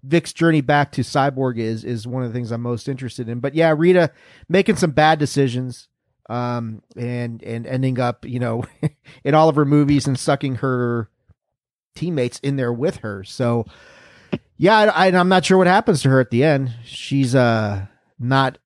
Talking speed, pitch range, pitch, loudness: 190 wpm, 120-155 Hz, 130 Hz, -19 LUFS